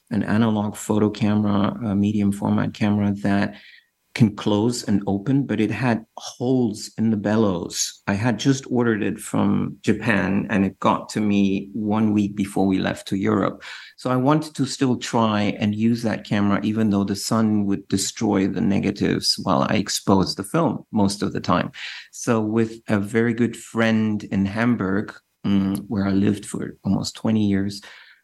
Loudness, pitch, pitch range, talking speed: -22 LUFS, 105 Hz, 100-115 Hz, 170 wpm